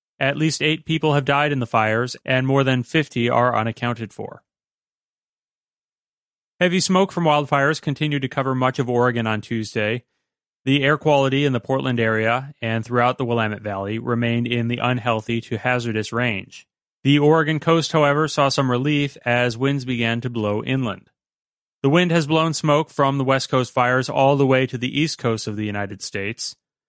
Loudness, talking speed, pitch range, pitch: -20 LUFS, 180 wpm, 115-145 Hz, 130 Hz